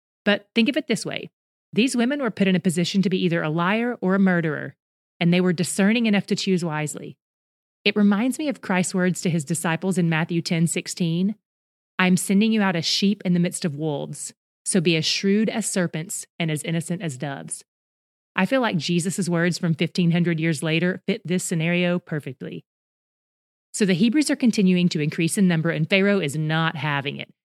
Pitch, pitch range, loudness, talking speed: 180 Hz, 165-200 Hz, -22 LUFS, 200 wpm